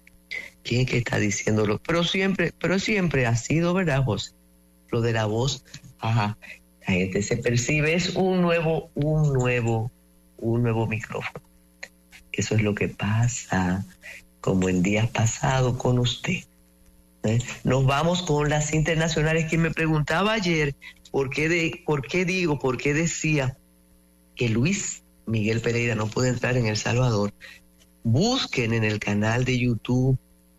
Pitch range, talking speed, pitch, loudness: 105-150 Hz, 150 wpm, 120 Hz, -24 LUFS